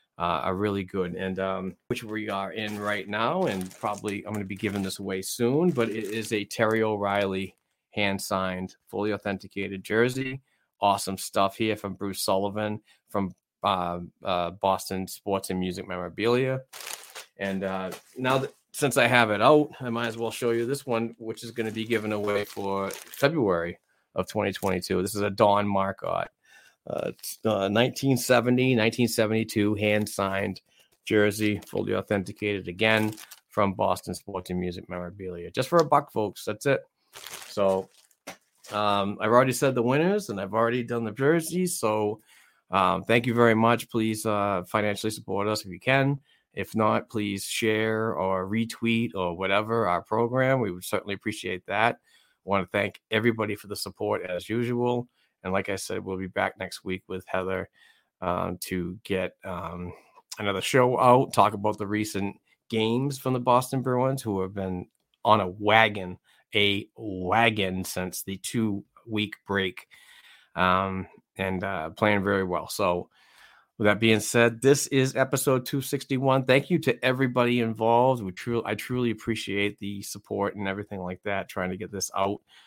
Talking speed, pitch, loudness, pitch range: 165 wpm, 105 Hz, -27 LUFS, 95-115 Hz